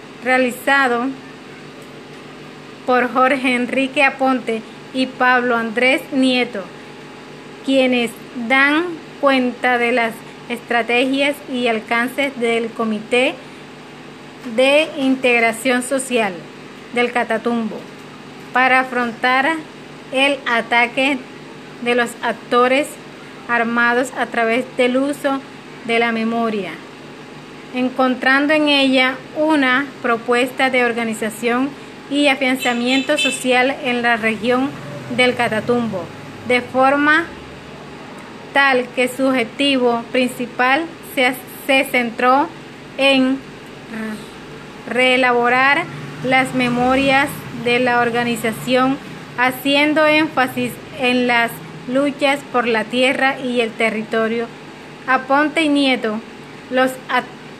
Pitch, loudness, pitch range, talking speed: 250 Hz, -17 LUFS, 235-270 Hz, 90 wpm